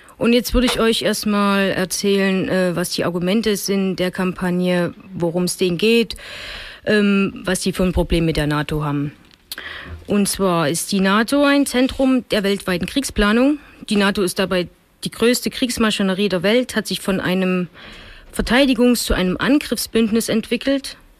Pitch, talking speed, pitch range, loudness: 200 Hz, 155 wpm, 185-230 Hz, -18 LUFS